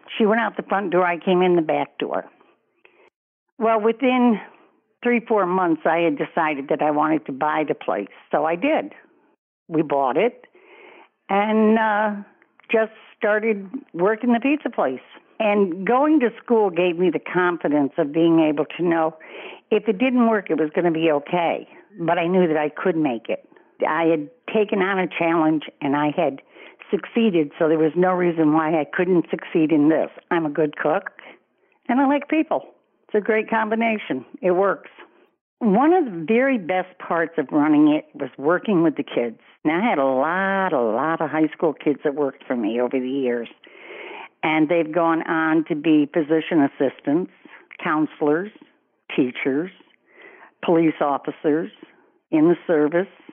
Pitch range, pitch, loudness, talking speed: 155-225 Hz, 180 Hz, -21 LUFS, 175 wpm